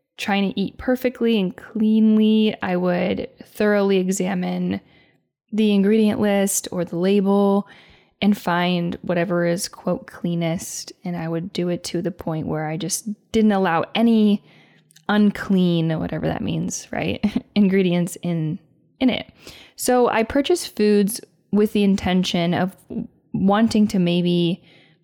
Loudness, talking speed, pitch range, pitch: -21 LUFS, 135 wpm, 175-215 Hz, 195 Hz